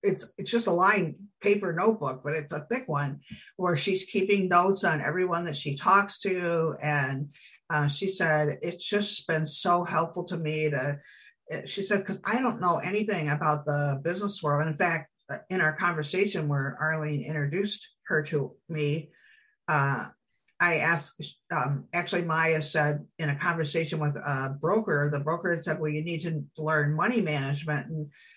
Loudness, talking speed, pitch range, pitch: -28 LUFS, 175 wpm, 150-190 Hz, 165 Hz